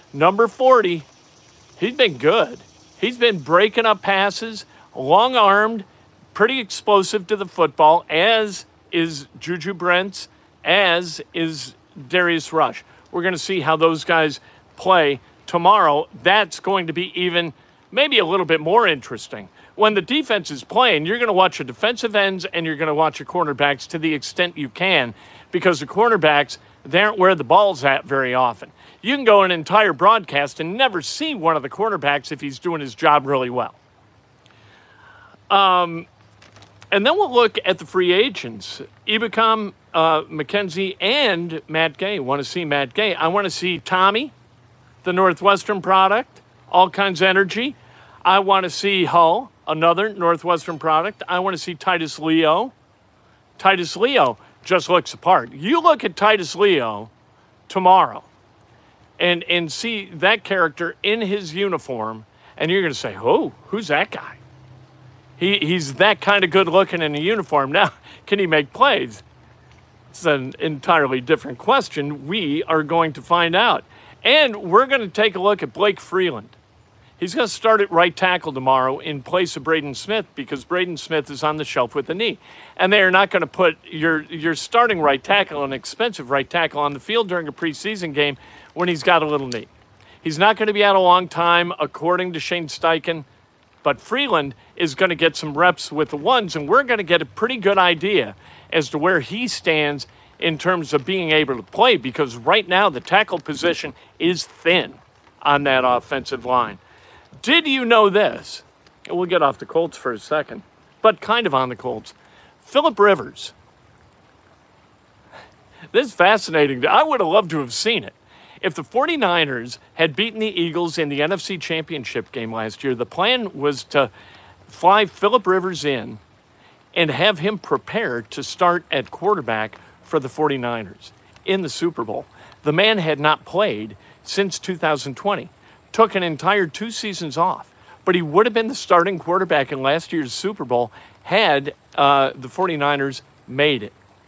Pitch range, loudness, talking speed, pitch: 145-195 Hz, -19 LUFS, 175 wpm, 170 Hz